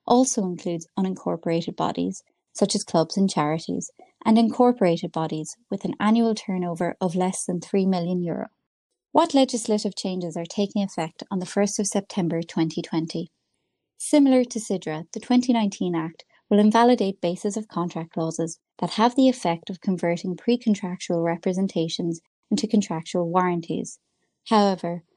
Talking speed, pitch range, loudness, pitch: 140 wpm, 170-220 Hz, -24 LUFS, 190 Hz